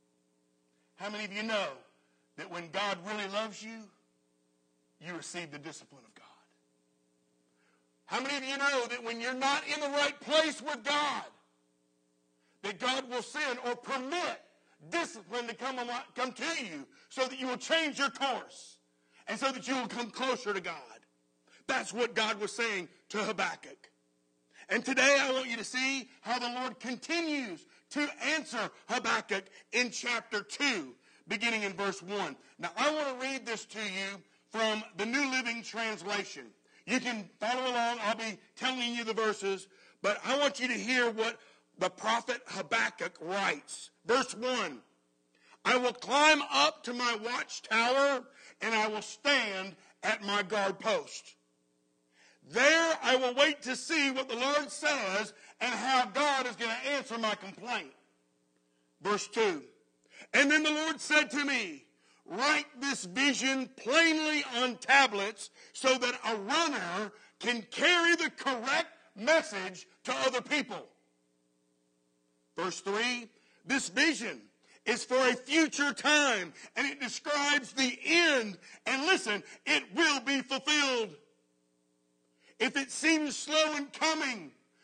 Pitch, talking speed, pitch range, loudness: 240 Hz, 150 wpm, 195-275 Hz, -31 LUFS